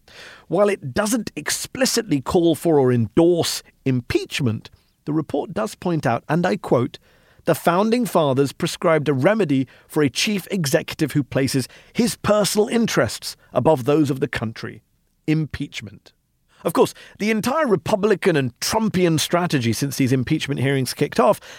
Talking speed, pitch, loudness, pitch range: 145 wpm, 155 Hz, -20 LUFS, 135-200 Hz